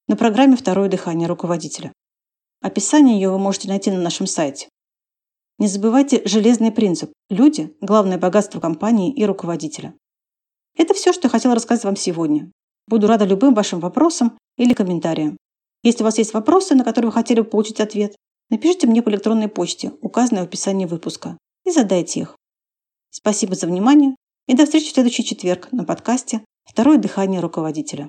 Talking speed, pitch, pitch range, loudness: 160 wpm, 215 Hz, 185-245 Hz, -17 LUFS